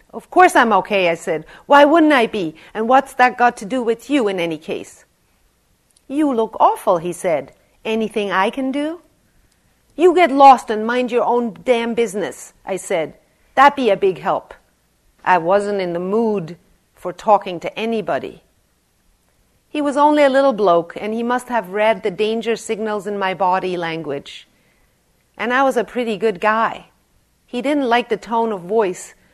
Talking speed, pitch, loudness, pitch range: 180 wpm, 220 Hz, -17 LUFS, 190-250 Hz